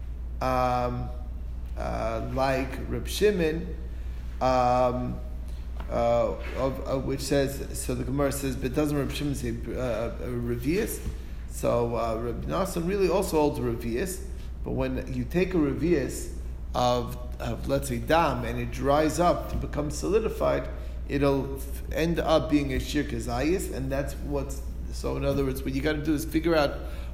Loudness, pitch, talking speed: -28 LUFS, 125 Hz, 155 wpm